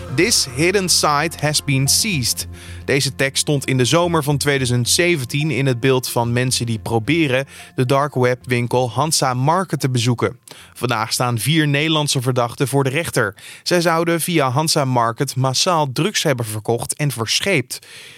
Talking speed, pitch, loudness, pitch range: 160 wpm, 135 Hz, -17 LUFS, 125-150 Hz